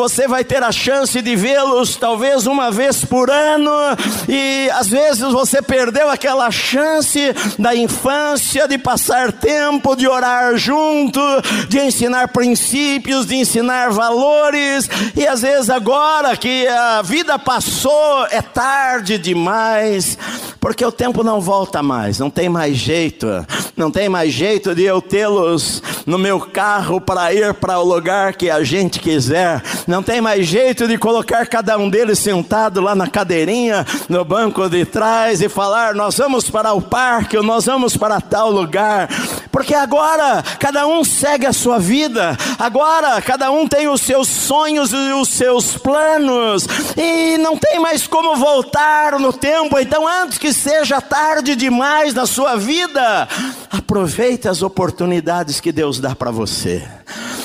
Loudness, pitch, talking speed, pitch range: -14 LUFS, 245 Hz, 150 wpm, 200-275 Hz